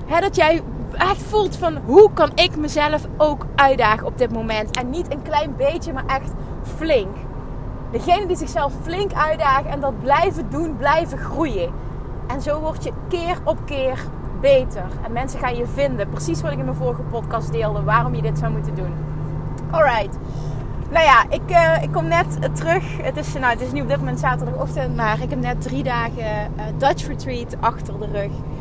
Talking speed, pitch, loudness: 190 wpm, 215 Hz, -20 LUFS